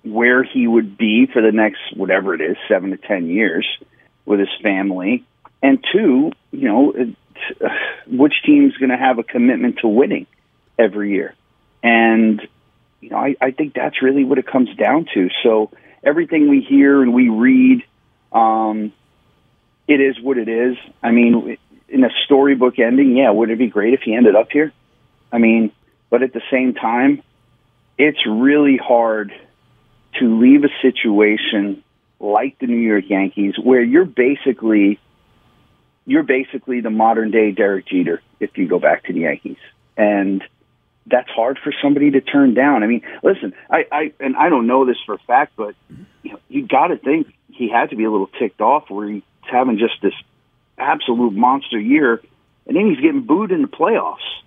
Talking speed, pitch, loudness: 185 wpm, 130 Hz, -16 LUFS